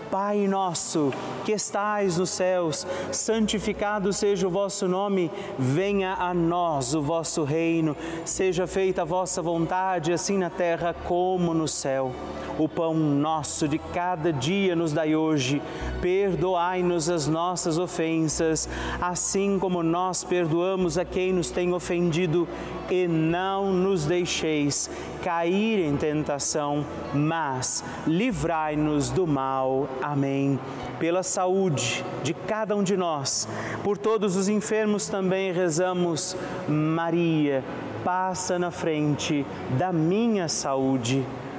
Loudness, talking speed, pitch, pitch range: -25 LUFS, 120 wpm, 175 Hz, 155-185 Hz